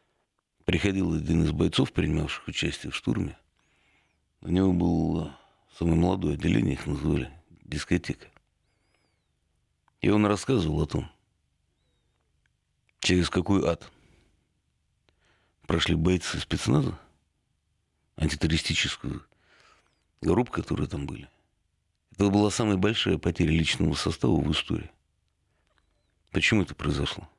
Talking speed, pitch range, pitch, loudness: 100 wpm, 75-95 Hz, 85 Hz, -27 LUFS